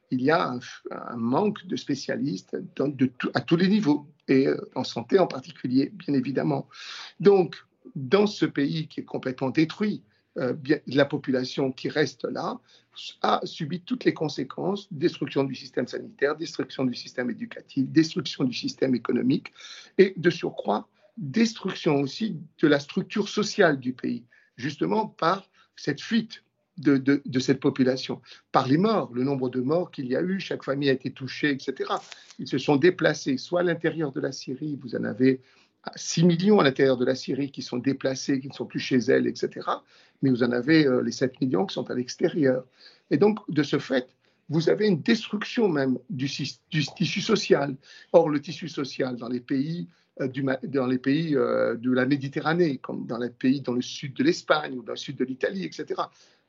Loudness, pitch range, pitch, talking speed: -26 LUFS, 130-180 Hz, 145 Hz, 190 wpm